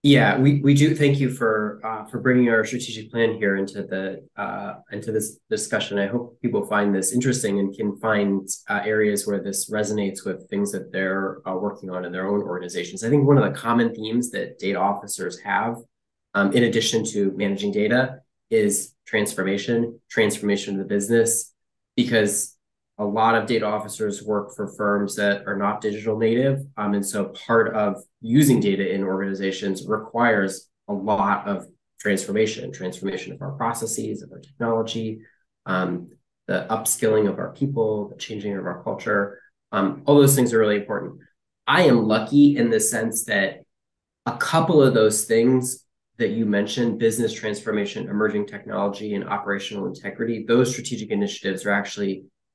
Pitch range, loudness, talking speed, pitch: 100-120 Hz, -22 LUFS, 170 wpm, 110 Hz